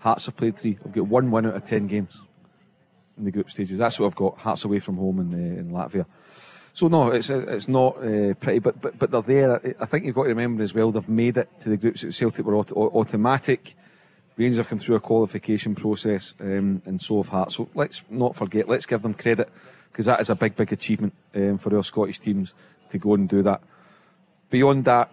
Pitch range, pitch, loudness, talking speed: 100-125 Hz, 110 Hz, -23 LUFS, 230 wpm